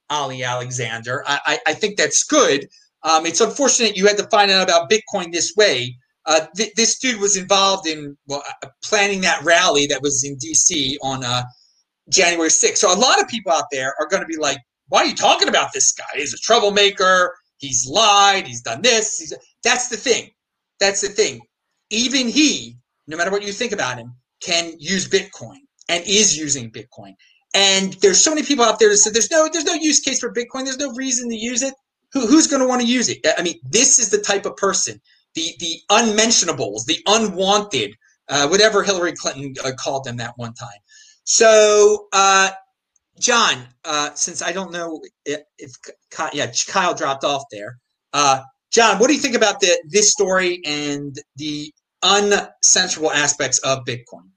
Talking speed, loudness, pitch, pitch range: 195 wpm, -16 LUFS, 190 Hz, 145-225 Hz